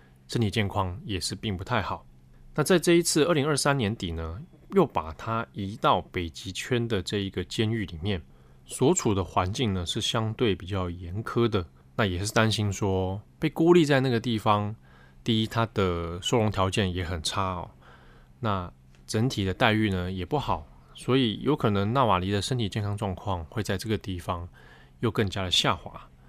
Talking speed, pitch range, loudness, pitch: 265 characters per minute, 90-115 Hz, -27 LUFS, 100 Hz